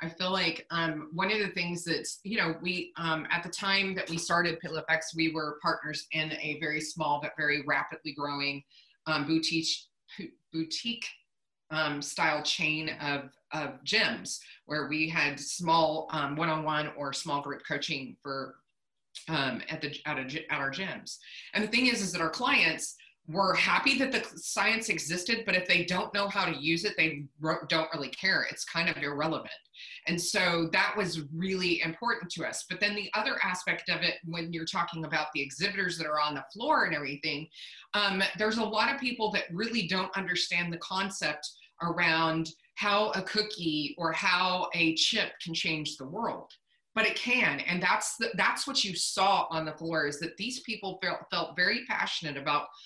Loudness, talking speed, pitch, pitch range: -30 LUFS, 195 wpm, 165 Hz, 155-195 Hz